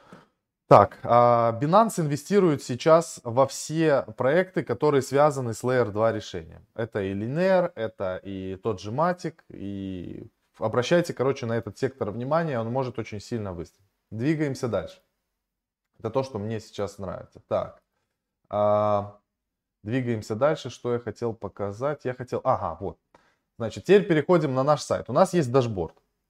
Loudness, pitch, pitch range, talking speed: -25 LUFS, 120 Hz, 105-150 Hz, 140 wpm